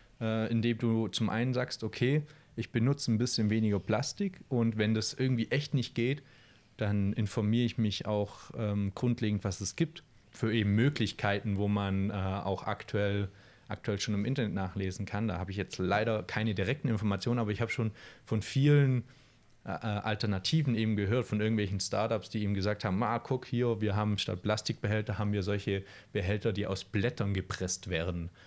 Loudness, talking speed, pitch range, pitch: -32 LUFS, 175 wpm, 100-120 Hz, 110 Hz